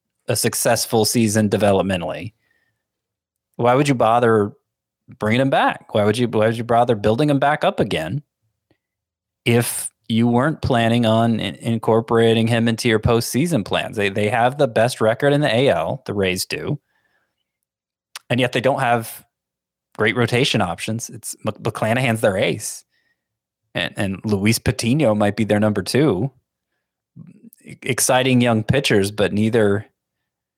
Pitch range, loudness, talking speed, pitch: 105-125 Hz, -19 LUFS, 140 wpm, 115 Hz